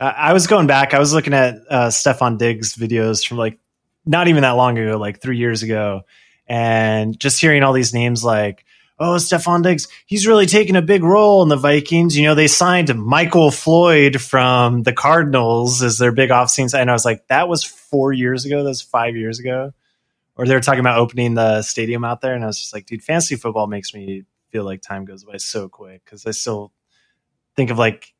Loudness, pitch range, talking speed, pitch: -15 LUFS, 115-150 Hz, 220 wpm, 125 Hz